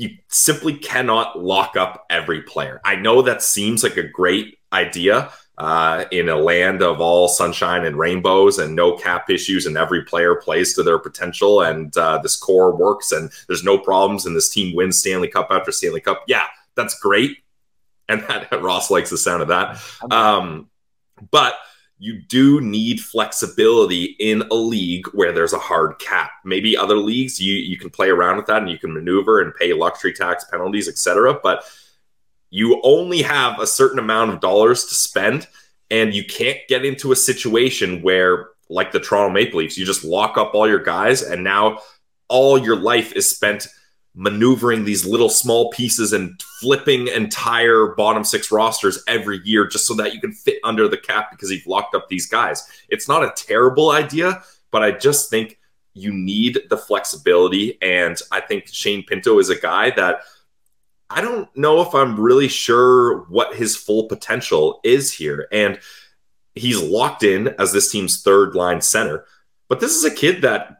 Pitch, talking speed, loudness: 130 Hz, 185 wpm, -17 LUFS